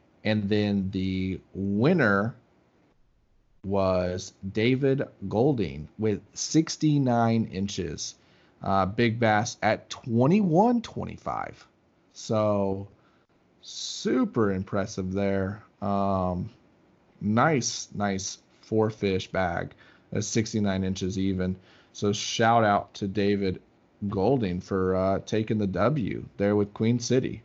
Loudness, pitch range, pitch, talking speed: -27 LUFS, 95-115 Hz, 100 Hz, 100 wpm